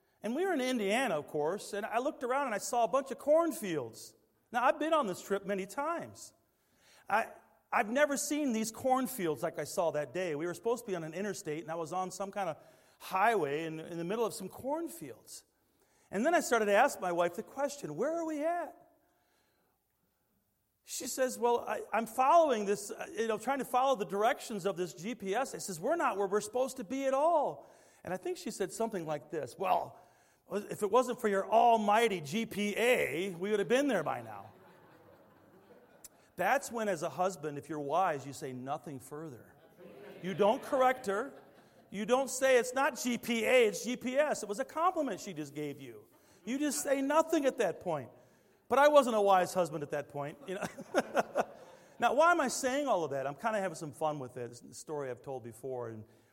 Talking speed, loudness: 210 wpm, -33 LUFS